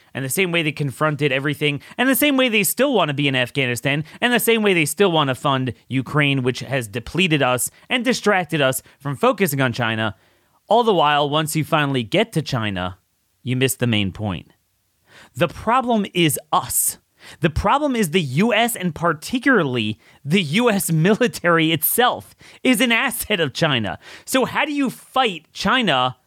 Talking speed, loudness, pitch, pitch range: 180 wpm, -19 LUFS, 155 Hz, 130-215 Hz